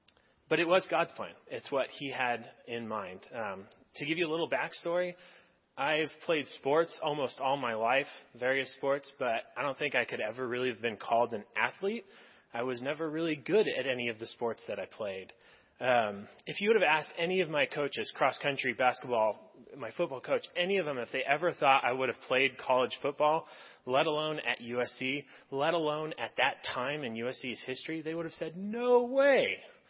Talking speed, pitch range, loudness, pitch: 195 wpm, 125-165 Hz, -32 LUFS, 145 Hz